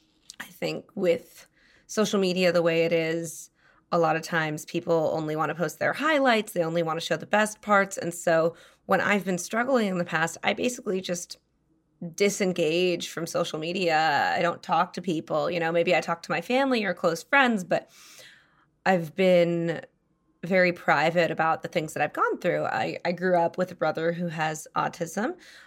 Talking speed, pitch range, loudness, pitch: 190 wpm, 165-185 Hz, -26 LUFS, 170 Hz